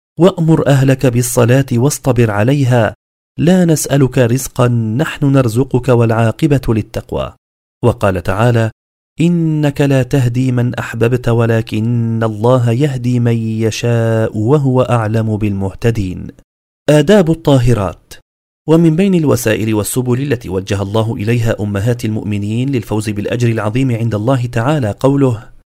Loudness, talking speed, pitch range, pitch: -13 LUFS, 105 wpm, 110-135 Hz, 120 Hz